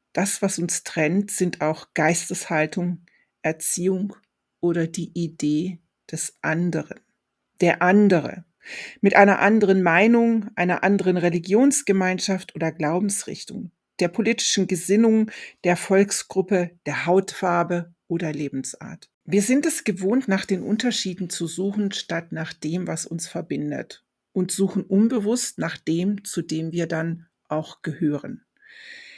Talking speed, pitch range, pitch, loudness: 120 wpm, 165-200 Hz, 180 Hz, -22 LUFS